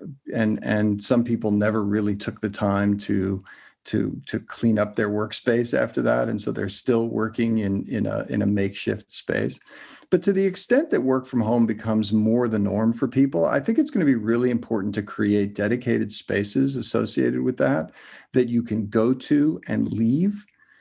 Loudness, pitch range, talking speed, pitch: -23 LUFS, 105-125 Hz, 190 wpm, 110 Hz